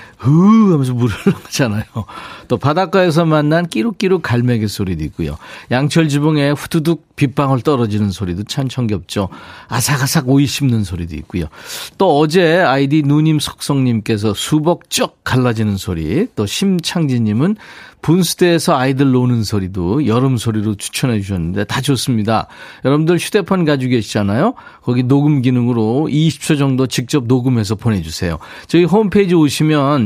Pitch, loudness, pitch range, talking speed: 135 Hz, -15 LUFS, 110-155 Hz, 350 characters per minute